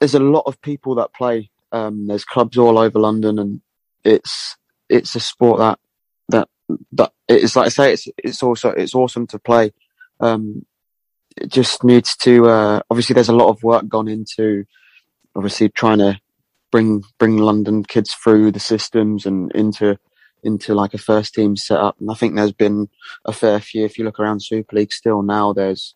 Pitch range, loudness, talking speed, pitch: 105-115 Hz, -16 LUFS, 190 wpm, 110 Hz